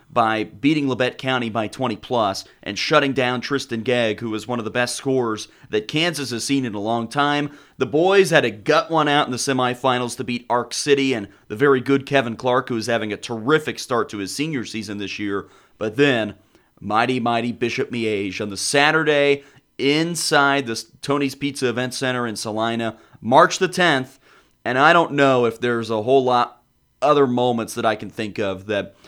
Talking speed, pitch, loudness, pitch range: 200 wpm, 125 Hz, -20 LUFS, 115-140 Hz